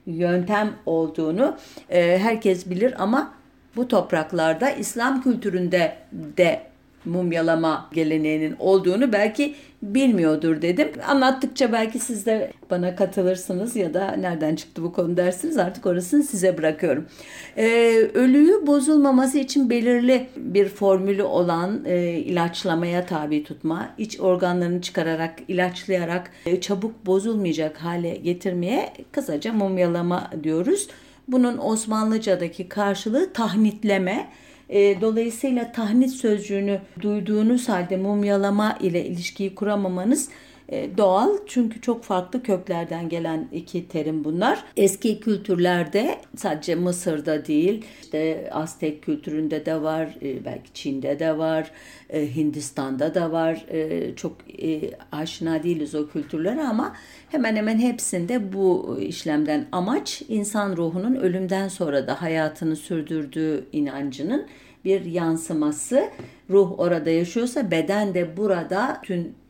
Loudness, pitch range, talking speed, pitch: -23 LUFS, 165-225 Hz, 110 wpm, 185 Hz